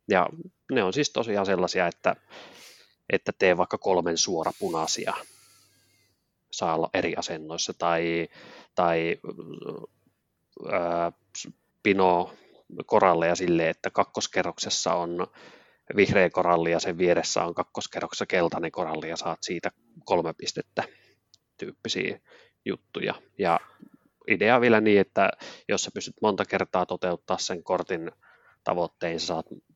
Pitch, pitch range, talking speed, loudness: 85 Hz, 85-95 Hz, 120 wpm, -26 LUFS